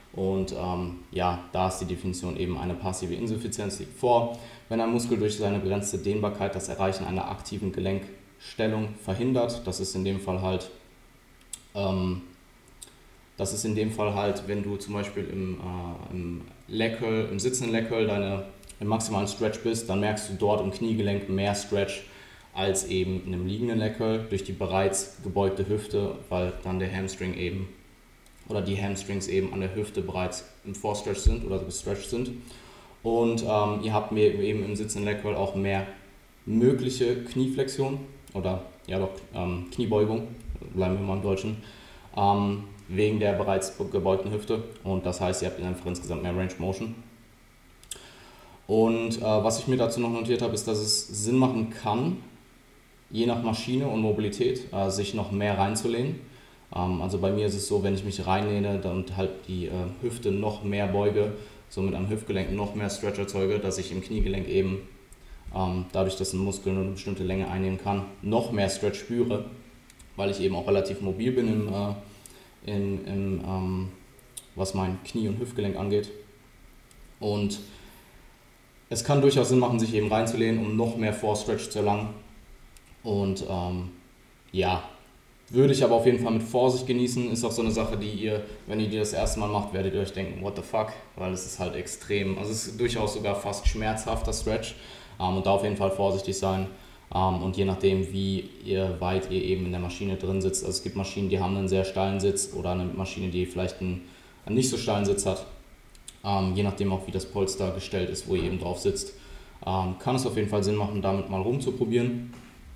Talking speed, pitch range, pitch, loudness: 185 wpm, 95-110 Hz, 100 Hz, -28 LUFS